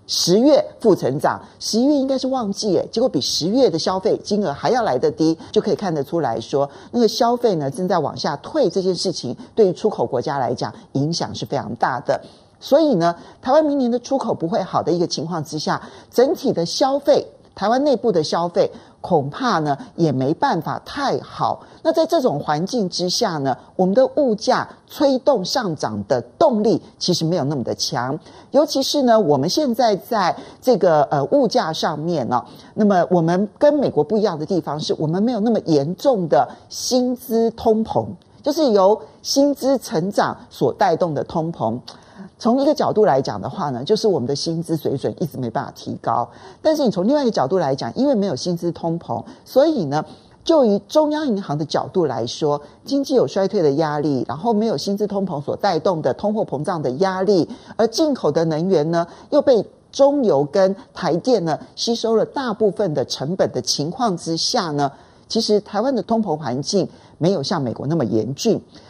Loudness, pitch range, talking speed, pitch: -19 LUFS, 160-245 Hz, 285 characters per minute, 200 Hz